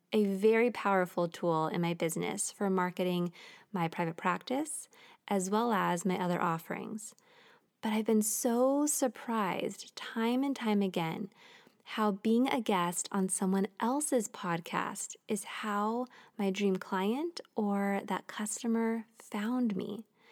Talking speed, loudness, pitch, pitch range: 135 wpm, -33 LUFS, 210 Hz, 190-235 Hz